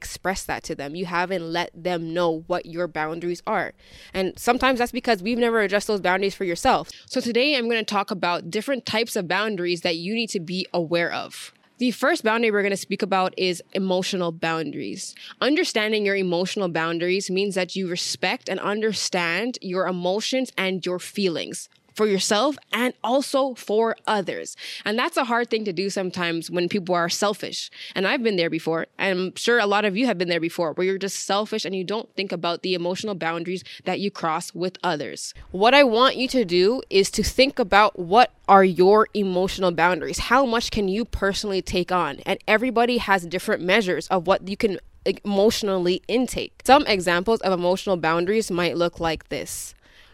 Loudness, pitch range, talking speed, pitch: -23 LUFS, 180-220 Hz, 195 wpm, 195 Hz